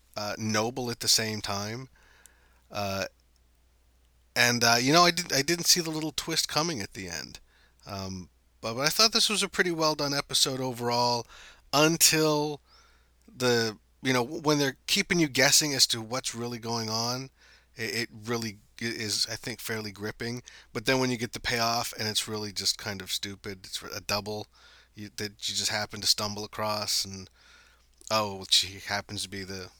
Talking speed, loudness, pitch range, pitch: 185 wpm, -27 LUFS, 100-130 Hz, 115 Hz